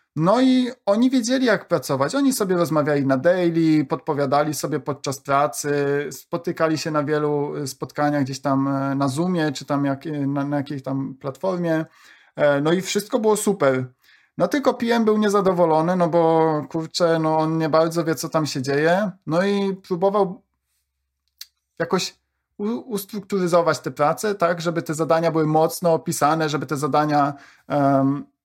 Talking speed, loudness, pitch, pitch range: 150 wpm, -21 LUFS, 160 Hz, 145-180 Hz